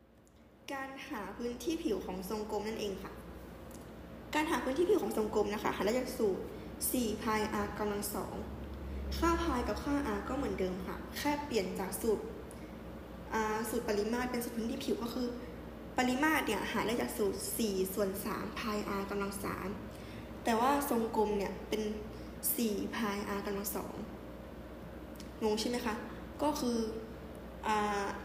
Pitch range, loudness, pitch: 205-250 Hz, -35 LUFS, 220 Hz